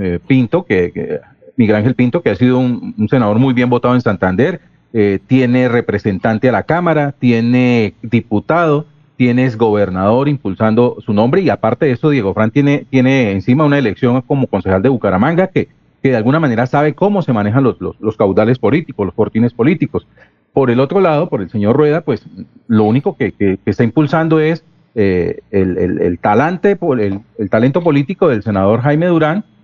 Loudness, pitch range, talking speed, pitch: -13 LUFS, 105-145 Hz, 185 wpm, 125 Hz